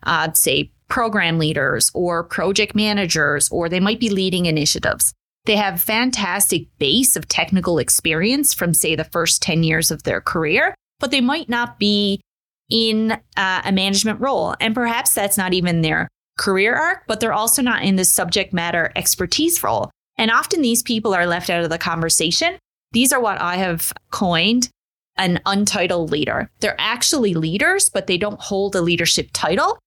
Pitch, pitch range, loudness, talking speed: 195 Hz, 170-225 Hz, -17 LUFS, 175 wpm